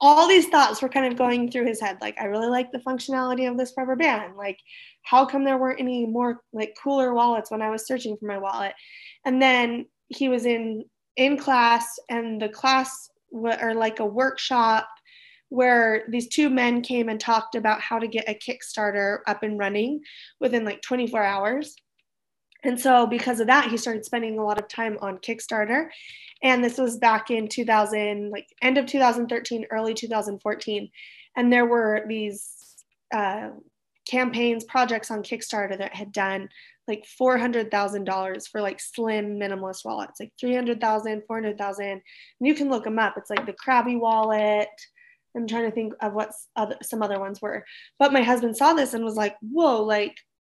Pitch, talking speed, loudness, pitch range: 230 Hz, 180 wpm, -24 LUFS, 215-255 Hz